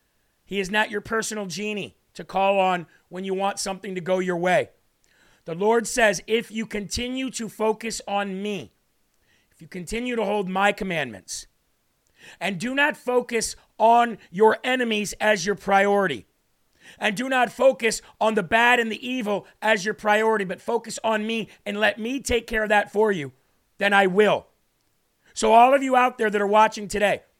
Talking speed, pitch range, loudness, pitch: 180 wpm, 195-225 Hz, -23 LUFS, 215 Hz